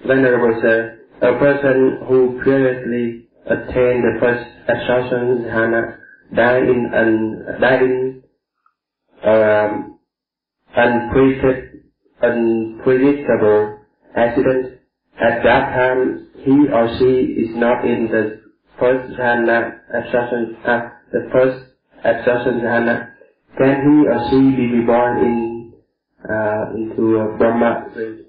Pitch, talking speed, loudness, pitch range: 120 Hz, 100 wpm, -16 LUFS, 115-130 Hz